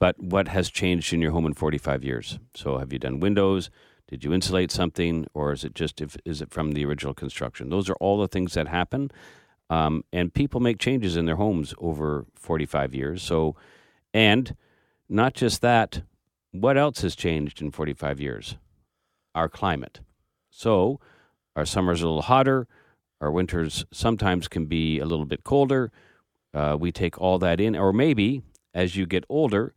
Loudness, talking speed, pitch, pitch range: -25 LUFS, 180 wpm, 85 Hz, 75-100 Hz